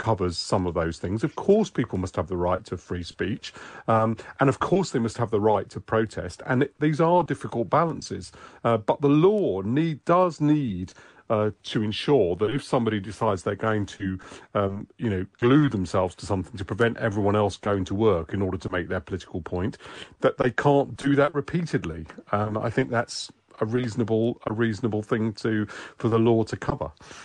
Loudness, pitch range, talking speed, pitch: -25 LUFS, 100-130 Hz, 200 wpm, 110 Hz